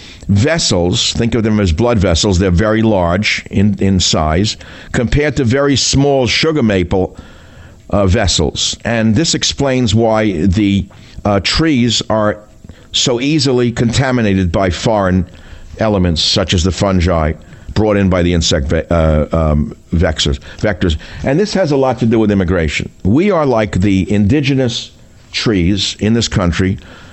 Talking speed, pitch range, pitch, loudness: 145 wpm, 90-115 Hz, 100 Hz, -13 LUFS